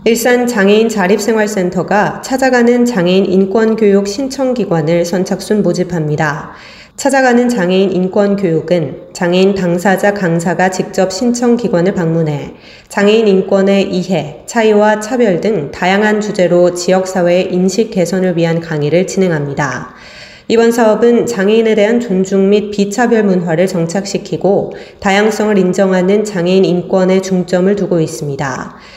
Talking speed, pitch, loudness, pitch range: 320 characters per minute, 190 Hz, -12 LUFS, 175-215 Hz